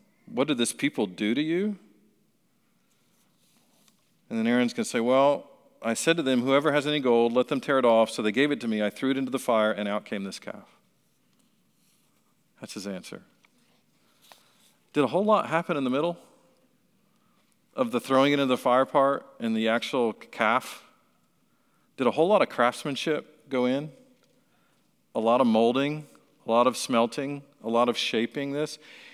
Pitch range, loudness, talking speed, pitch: 120-150 Hz, -26 LUFS, 180 wpm, 135 Hz